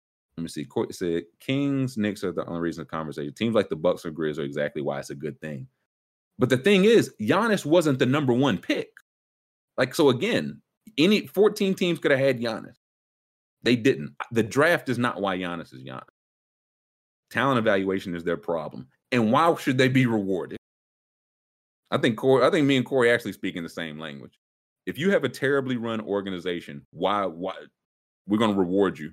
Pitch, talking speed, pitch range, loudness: 105 Hz, 195 wpm, 85-135 Hz, -24 LUFS